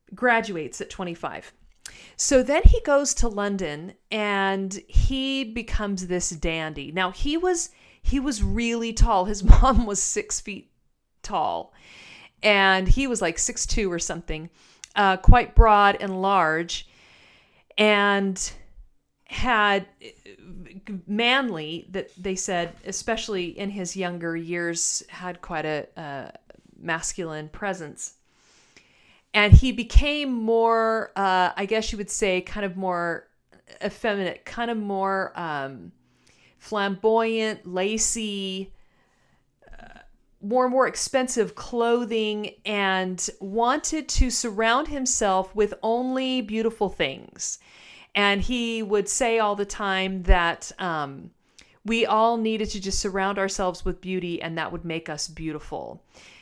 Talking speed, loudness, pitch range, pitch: 125 wpm, -24 LUFS, 185-225 Hz, 200 Hz